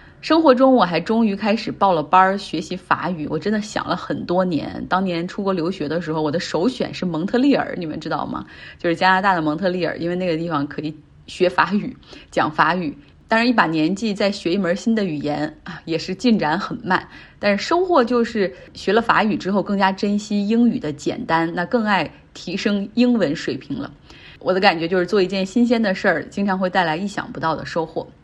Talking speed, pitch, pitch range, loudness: 320 characters per minute, 185 Hz, 170-215 Hz, -20 LUFS